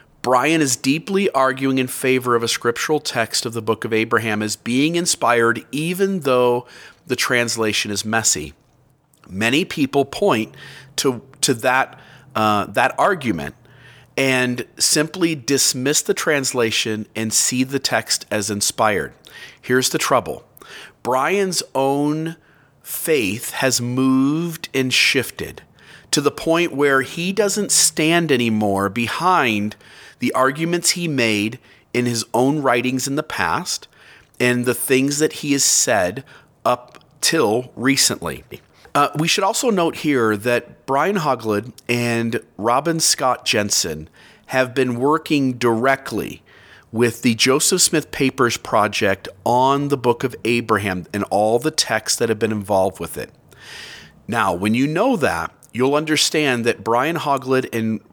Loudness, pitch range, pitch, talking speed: -18 LUFS, 115-145 Hz, 130 Hz, 135 wpm